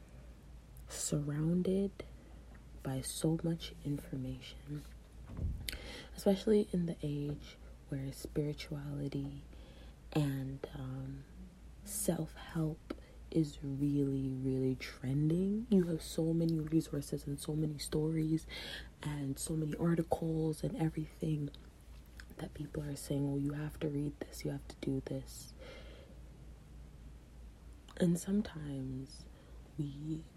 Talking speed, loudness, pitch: 100 wpm, -38 LUFS, 145 Hz